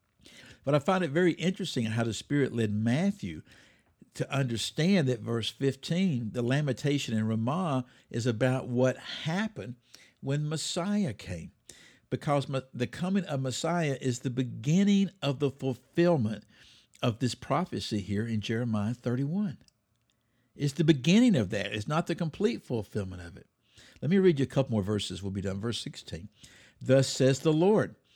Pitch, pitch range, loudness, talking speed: 130 Hz, 115-160 Hz, -29 LUFS, 160 wpm